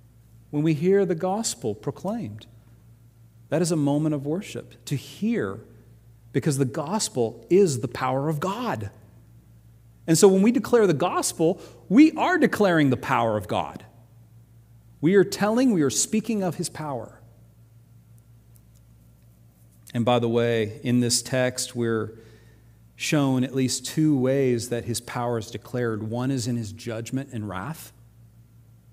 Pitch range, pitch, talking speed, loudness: 115-155 Hz, 120 Hz, 145 wpm, -24 LUFS